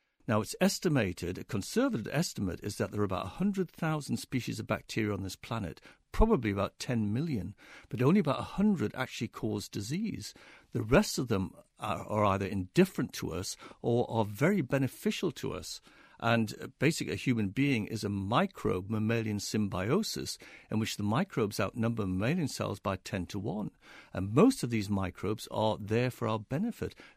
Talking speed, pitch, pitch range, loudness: 170 wpm, 110 Hz, 105-140 Hz, -32 LUFS